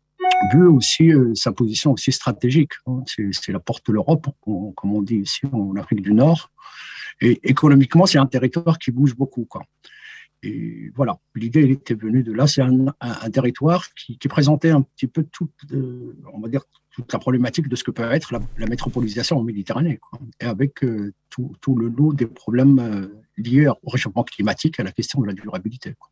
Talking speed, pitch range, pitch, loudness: 205 wpm, 115-145 Hz, 130 Hz, -19 LUFS